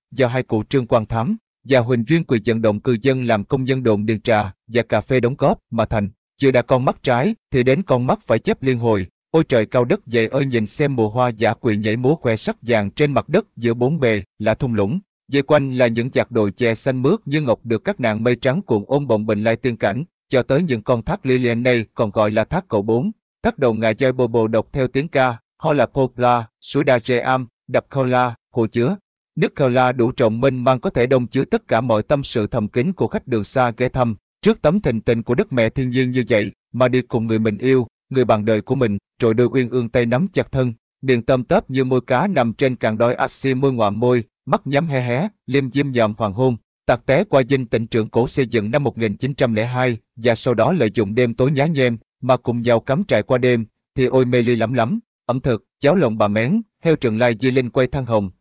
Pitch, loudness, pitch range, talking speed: 125 Hz, -19 LUFS, 115-135 Hz, 255 wpm